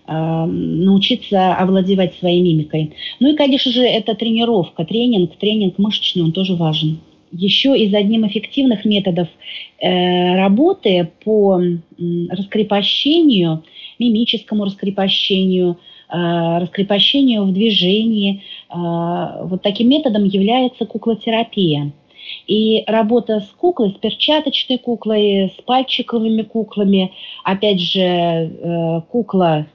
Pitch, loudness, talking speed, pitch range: 200 Hz, -16 LUFS, 105 wpm, 180-225 Hz